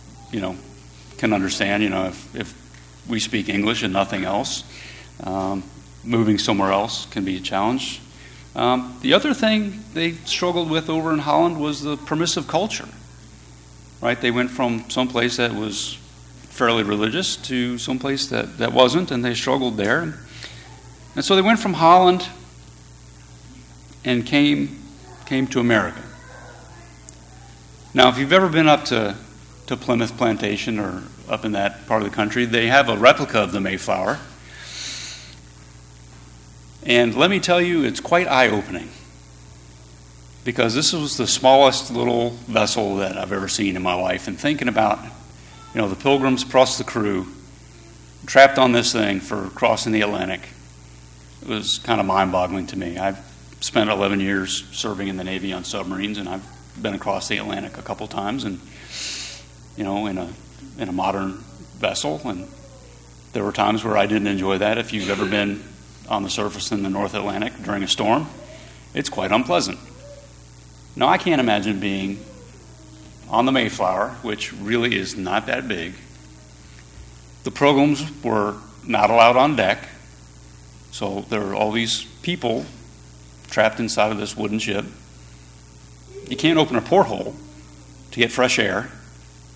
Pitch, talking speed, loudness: 100 Hz, 155 wpm, -20 LUFS